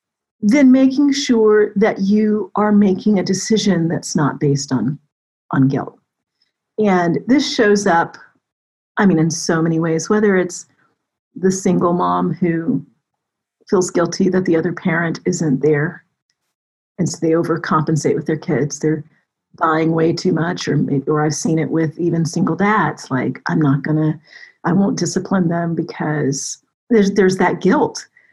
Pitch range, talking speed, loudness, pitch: 155-200 Hz, 160 wpm, -17 LUFS, 170 Hz